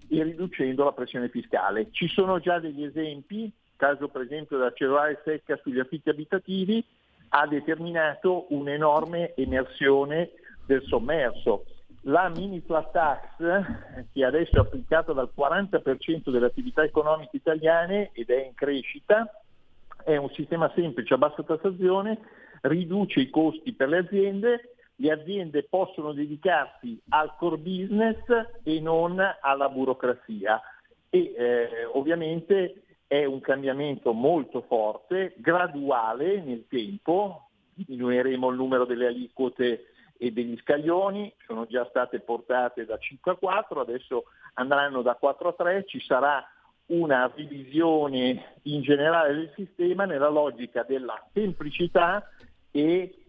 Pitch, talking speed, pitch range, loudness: 155 Hz, 130 wpm, 135-185 Hz, -26 LUFS